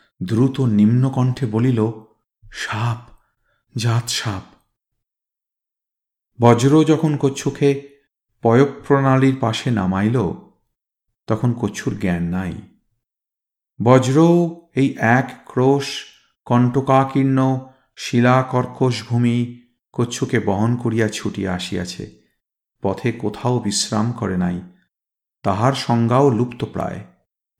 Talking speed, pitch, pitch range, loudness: 85 wpm, 120 Hz, 110-135 Hz, -19 LUFS